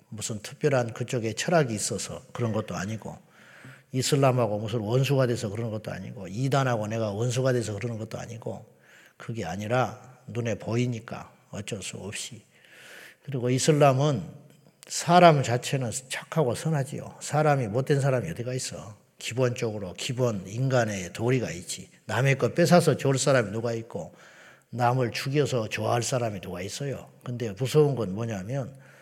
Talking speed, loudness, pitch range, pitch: 335 characters per minute, -27 LUFS, 115-140 Hz, 125 Hz